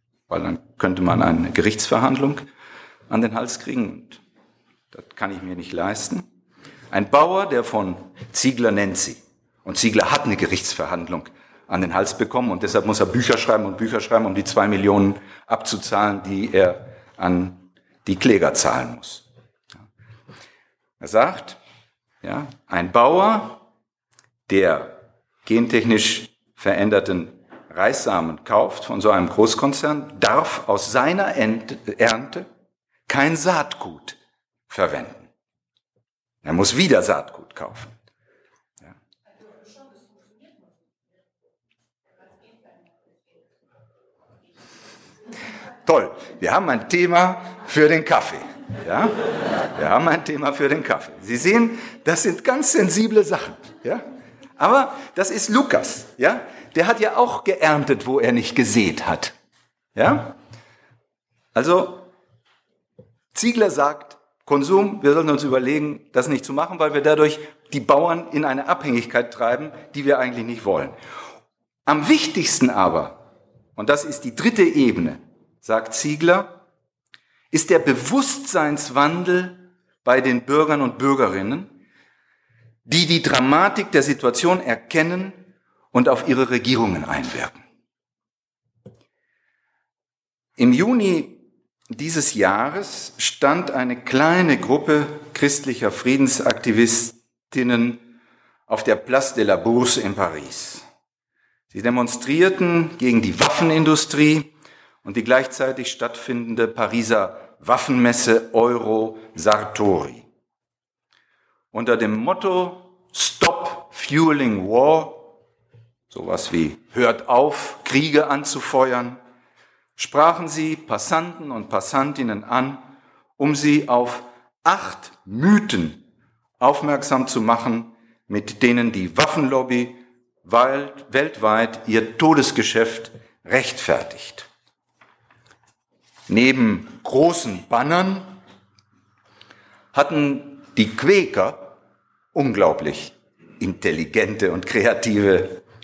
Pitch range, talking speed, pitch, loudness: 115-170 Hz, 105 wpm, 140 Hz, -19 LUFS